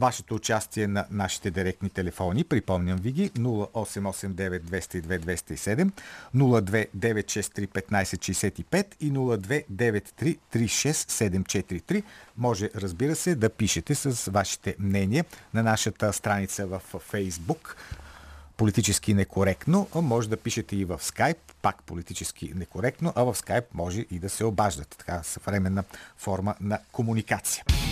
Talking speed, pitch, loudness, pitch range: 110 wpm, 100 Hz, -28 LUFS, 95-115 Hz